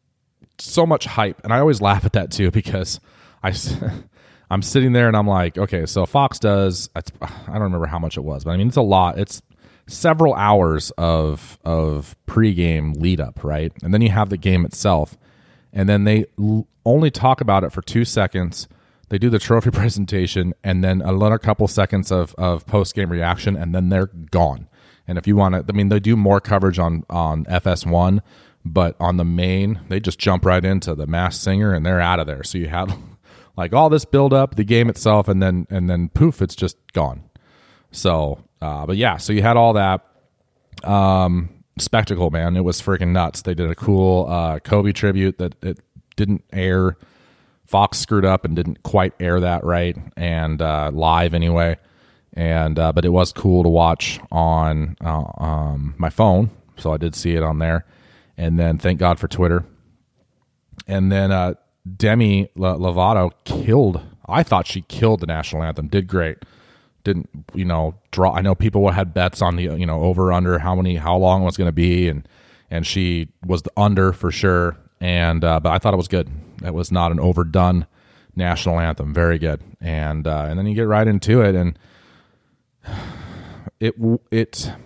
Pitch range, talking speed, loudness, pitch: 85-105 Hz, 195 wpm, -19 LUFS, 90 Hz